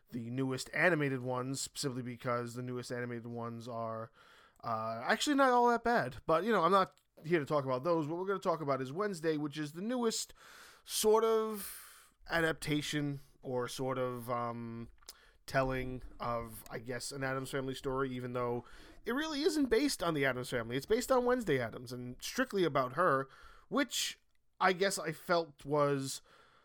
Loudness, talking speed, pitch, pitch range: -34 LUFS, 180 wpm, 140 Hz, 125-180 Hz